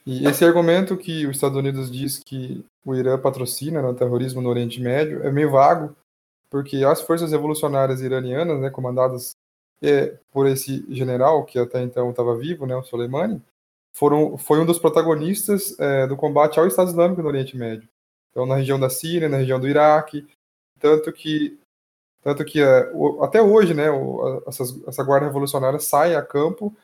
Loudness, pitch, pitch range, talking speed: -20 LUFS, 140 Hz, 130-155 Hz, 170 wpm